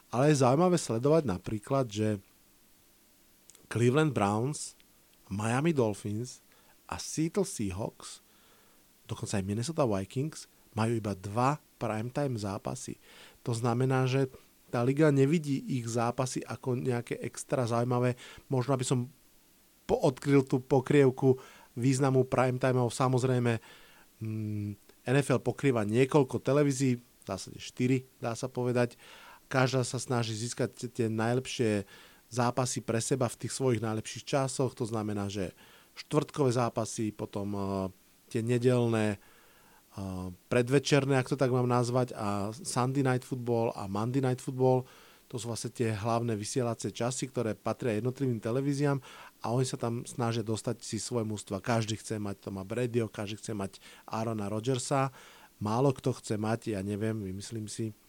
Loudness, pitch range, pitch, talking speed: -31 LUFS, 110-130 Hz, 120 Hz, 135 wpm